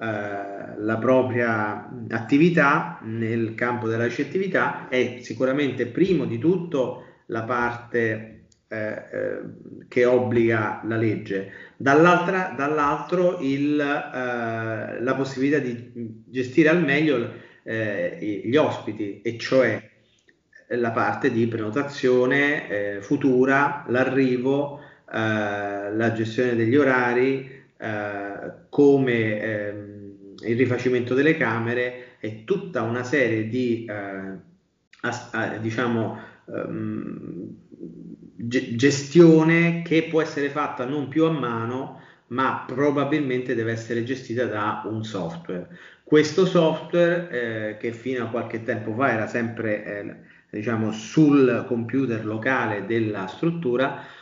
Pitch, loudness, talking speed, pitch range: 125 Hz, -23 LUFS, 110 wpm, 110-140 Hz